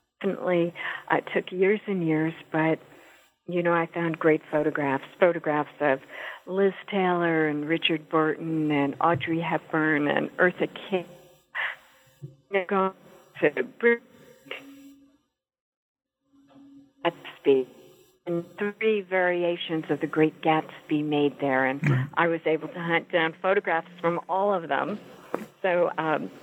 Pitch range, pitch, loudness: 155-195 Hz, 170 Hz, -26 LUFS